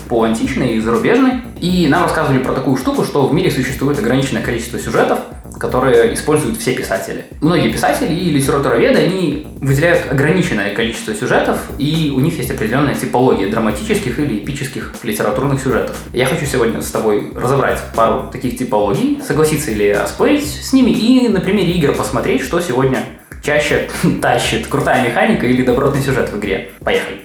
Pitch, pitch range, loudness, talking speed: 140 Hz, 125-170 Hz, -15 LUFS, 160 wpm